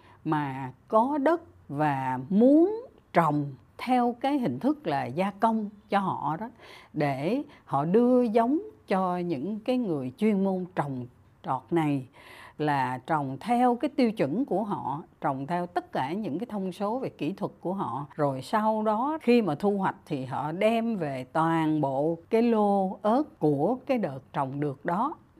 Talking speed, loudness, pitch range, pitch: 170 wpm, -27 LUFS, 145-230 Hz, 185 Hz